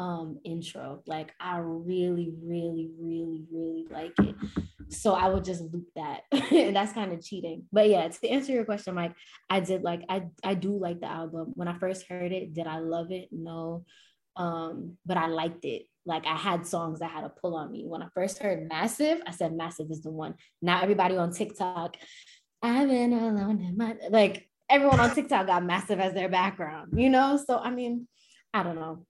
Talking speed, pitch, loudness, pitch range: 205 wpm, 180 Hz, -29 LUFS, 165-205 Hz